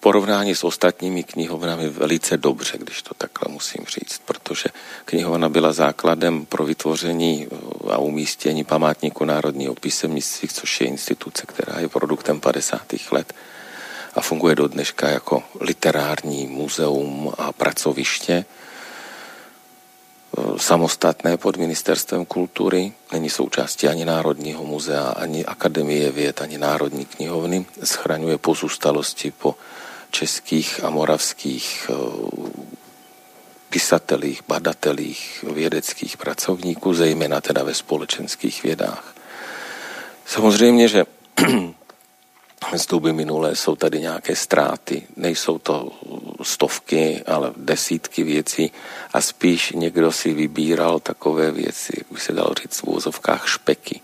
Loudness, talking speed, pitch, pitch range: -21 LUFS, 110 wpm, 80 Hz, 75-85 Hz